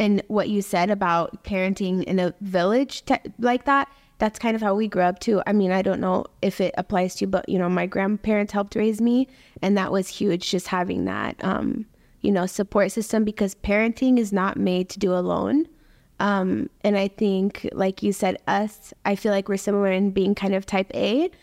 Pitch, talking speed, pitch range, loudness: 200 Hz, 215 wpm, 190-220 Hz, -23 LUFS